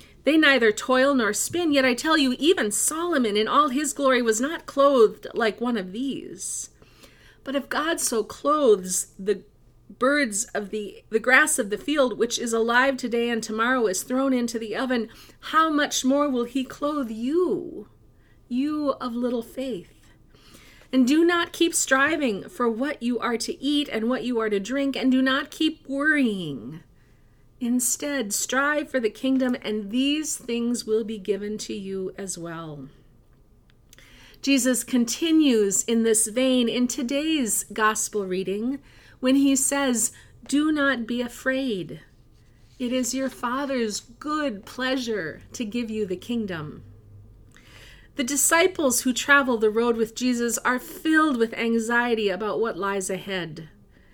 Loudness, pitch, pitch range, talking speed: -23 LUFS, 245 Hz, 210-275 Hz, 155 wpm